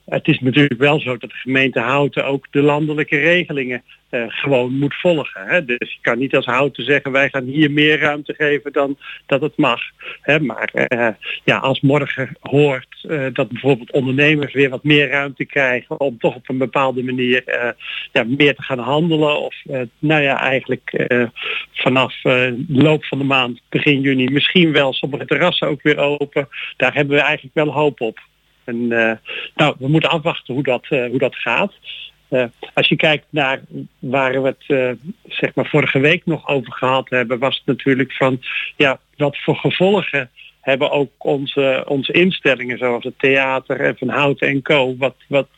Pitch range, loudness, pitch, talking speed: 130-150 Hz, -17 LUFS, 140 Hz, 190 wpm